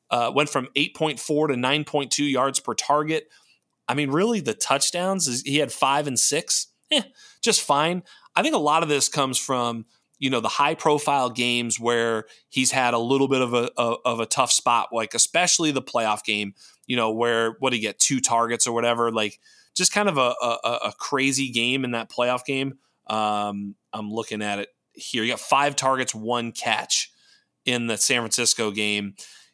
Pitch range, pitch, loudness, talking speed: 115-145 Hz, 130 Hz, -22 LUFS, 190 wpm